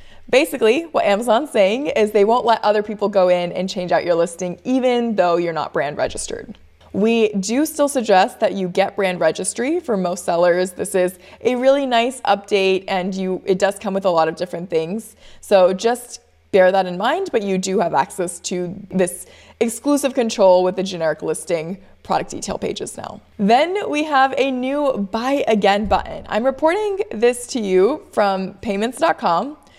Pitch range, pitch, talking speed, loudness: 185-245 Hz, 200 Hz, 180 wpm, -18 LUFS